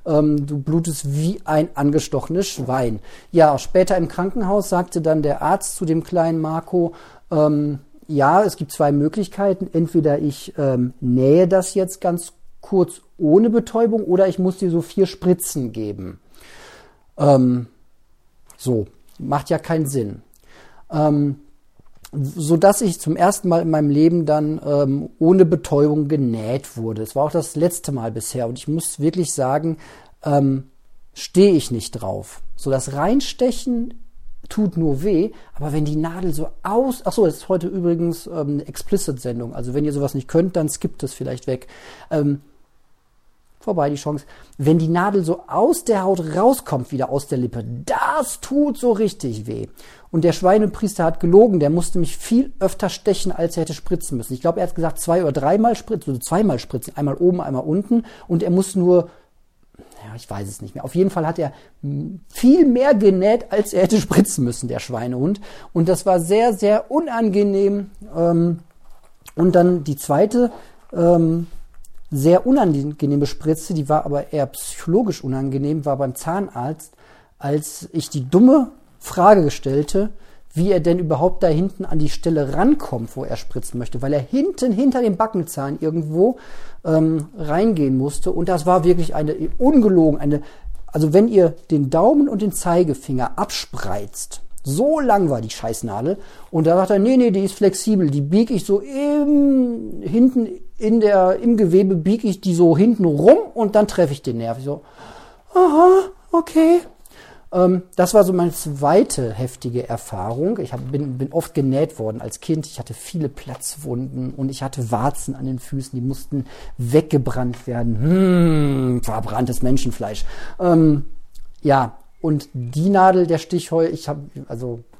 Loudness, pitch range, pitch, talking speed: -19 LUFS, 140-190 Hz, 165 Hz, 165 wpm